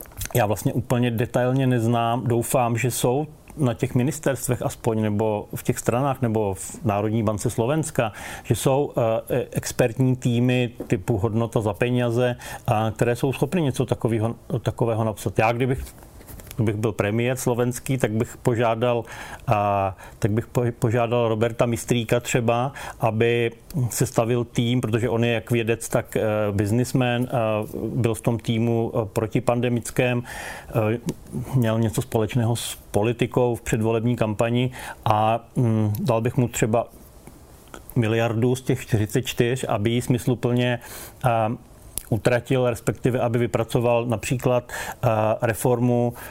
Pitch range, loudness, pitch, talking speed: 115-125 Hz, -23 LUFS, 120 Hz, 120 wpm